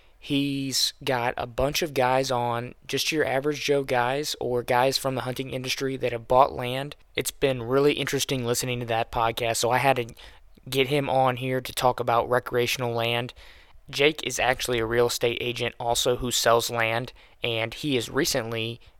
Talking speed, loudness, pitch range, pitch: 185 wpm, -25 LUFS, 120-135 Hz, 125 Hz